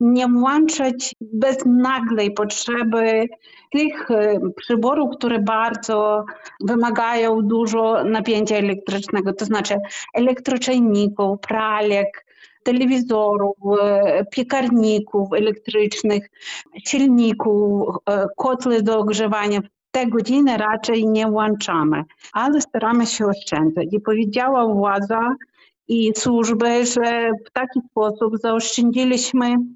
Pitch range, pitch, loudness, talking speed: 210-245 Hz, 225 Hz, -19 LUFS, 85 wpm